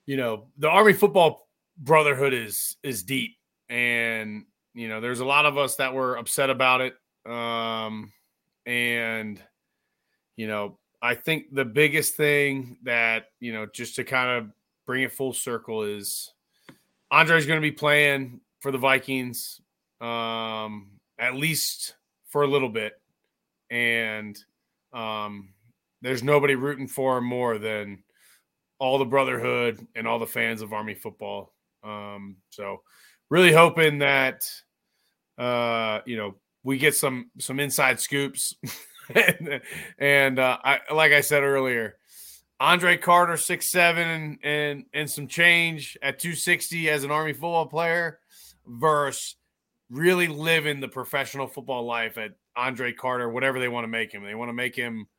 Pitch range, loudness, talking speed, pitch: 115-145 Hz, -23 LUFS, 150 wpm, 130 Hz